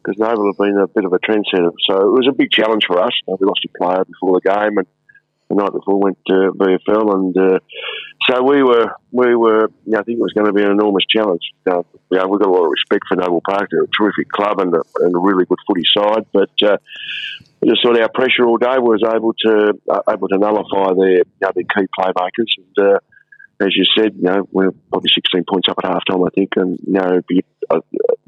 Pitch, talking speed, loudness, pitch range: 100 Hz, 255 wpm, -15 LUFS, 95-115 Hz